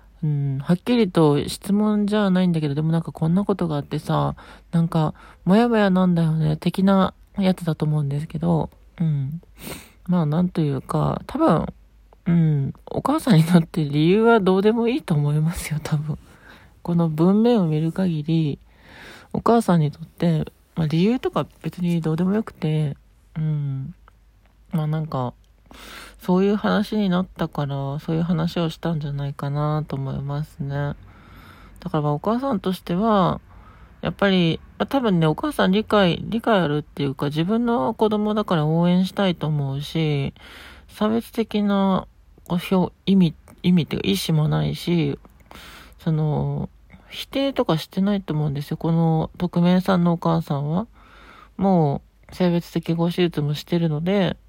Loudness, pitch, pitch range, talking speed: -22 LUFS, 170 Hz, 150-195 Hz, 310 characters per minute